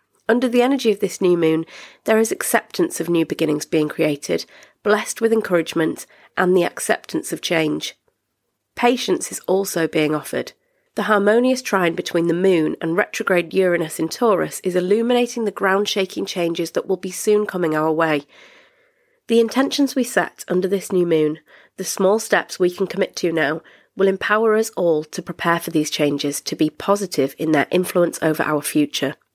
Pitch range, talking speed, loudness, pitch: 165-215 Hz, 175 wpm, -20 LUFS, 185 Hz